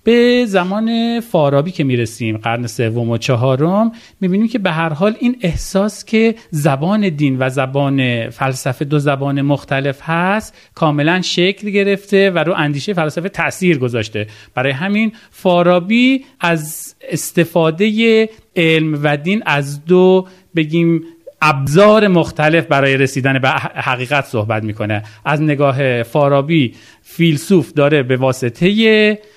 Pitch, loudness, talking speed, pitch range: 160 Hz, -15 LUFS, 125 wpm, 135-195 Hz